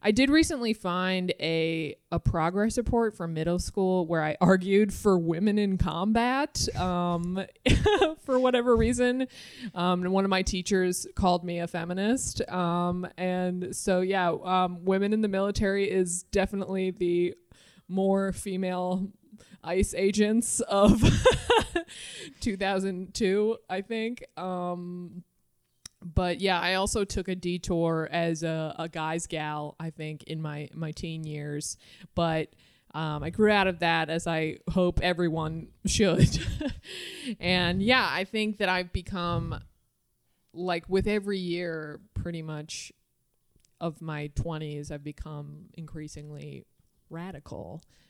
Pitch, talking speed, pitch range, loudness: 180 Hz, 130 wpm, 165-200 Hz, -28 LUFS